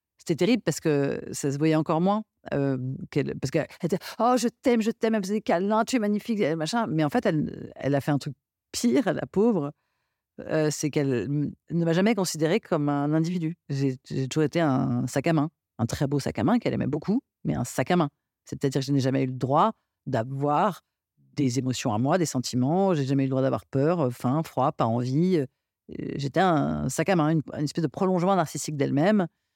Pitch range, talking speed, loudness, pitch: 135-180 Hz, 220 wpm, -26 LUFS, 155 Hz